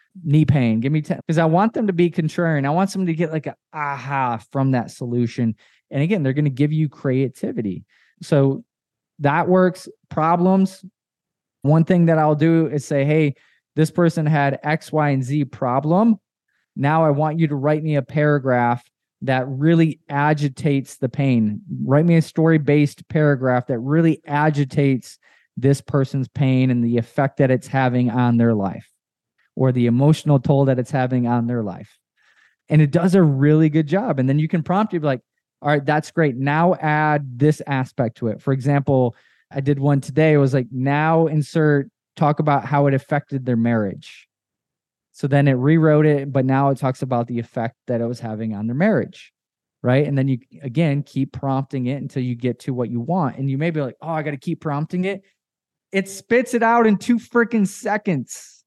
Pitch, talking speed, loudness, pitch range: 145 Hz, 195 wpm, -19 LUFS, 130-160 Hz